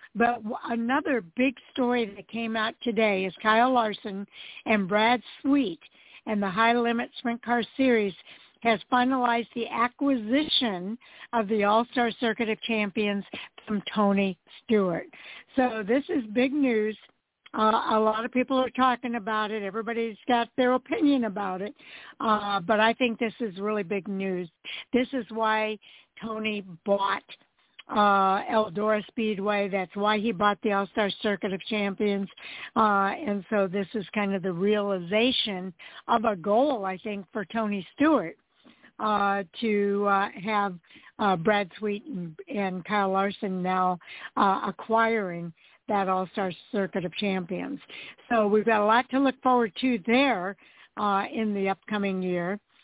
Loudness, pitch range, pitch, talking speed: -26 LUFS, 200-235 Hz, 215 Hz, 150 wpm